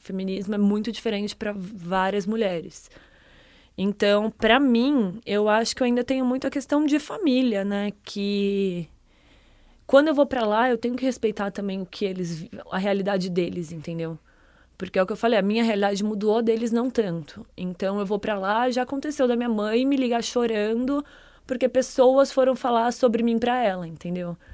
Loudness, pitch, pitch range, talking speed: -24 LUFS, 215 Hz, 195-245 Hz, 185 wpm